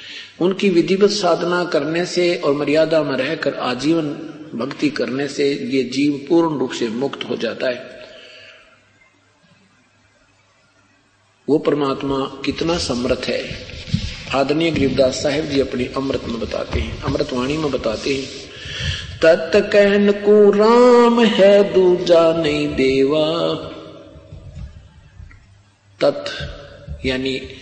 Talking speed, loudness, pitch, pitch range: 105 wpm, -17 LUFS, 145 Hz, 130-170 Hz